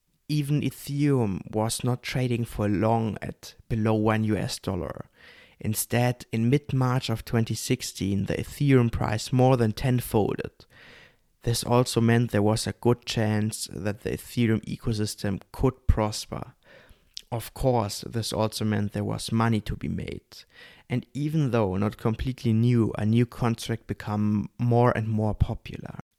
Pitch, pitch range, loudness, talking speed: 115 Hz, 105-125 Hz, -26 LUFS, 145 wpm